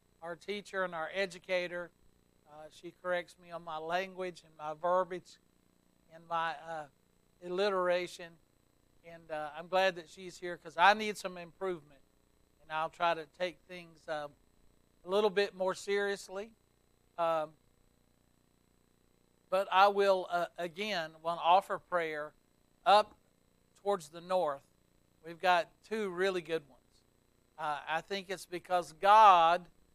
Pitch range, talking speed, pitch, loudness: 145-185 Hz, 140 wpm, 170 Hz, -32 LUFS